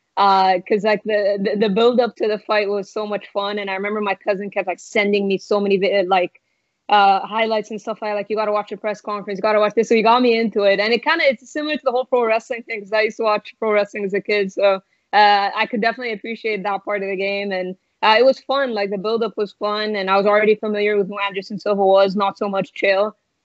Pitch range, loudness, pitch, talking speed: 200-220 Hz, -19 LUFS, 210 Hz, 275 wpm